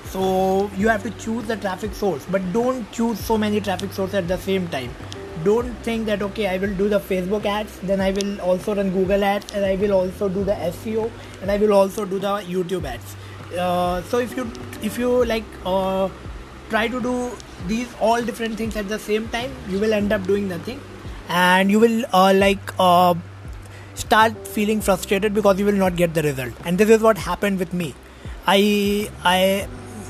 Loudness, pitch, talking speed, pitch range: -21 LUFS, 200 Hz, 200 wpm, 185-215 Hz